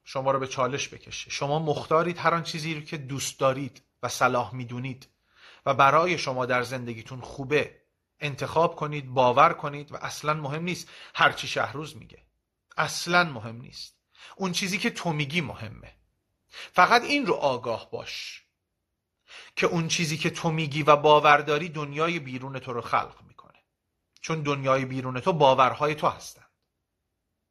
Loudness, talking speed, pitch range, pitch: -25 LUFS, 150 wpm, 130-160 Hz, 145 Hz